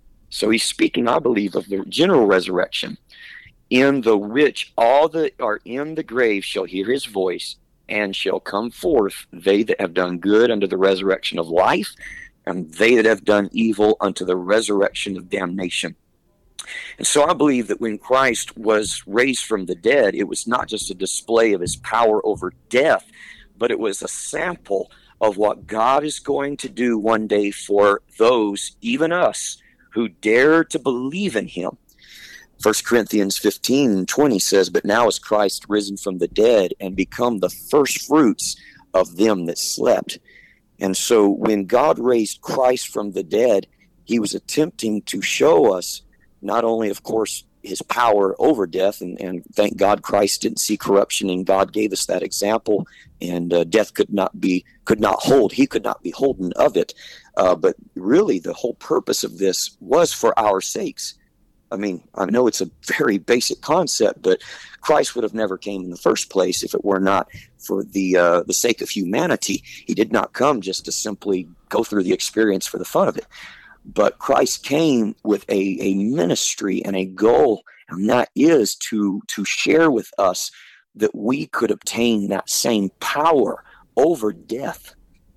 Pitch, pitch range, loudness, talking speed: 105 Hz, 95-125 Hz, -19 LUFS, 180 wpm